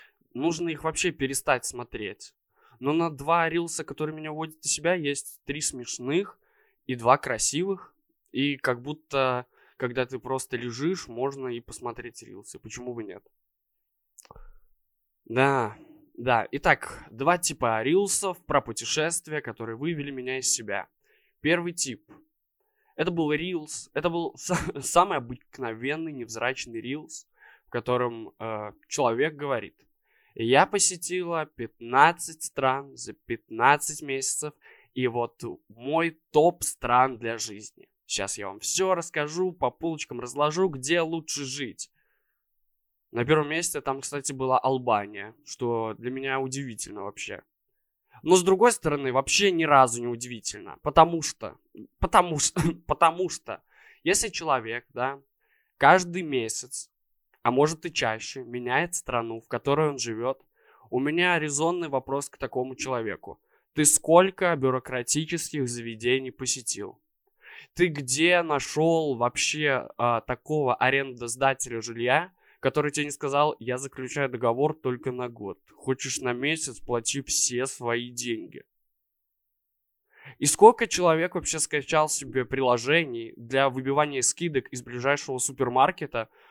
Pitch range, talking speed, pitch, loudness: 125-160 Hz, 125 wpm, 140 Hz, -26 LUFS